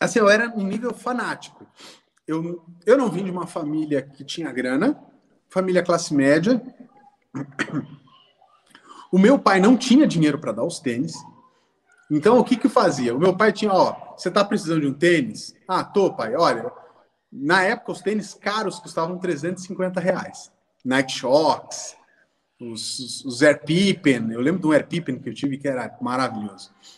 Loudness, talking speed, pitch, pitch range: -21 LUFS, 170 wpm, 180 Hz, 145-215 Hz